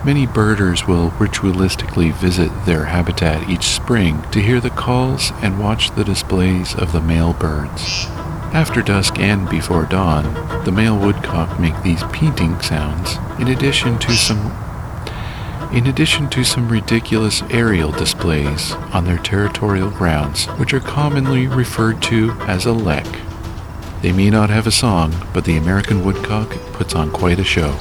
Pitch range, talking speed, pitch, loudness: 85-115 Hz, 155 wpm, 100 Hz, -16 LUFS